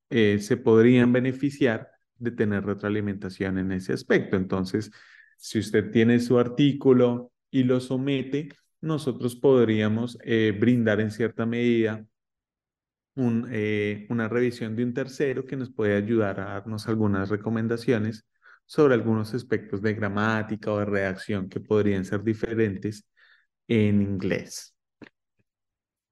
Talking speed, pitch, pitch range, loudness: 125 wpm, 110 Hz, 105-120 Hz, -25 LUFS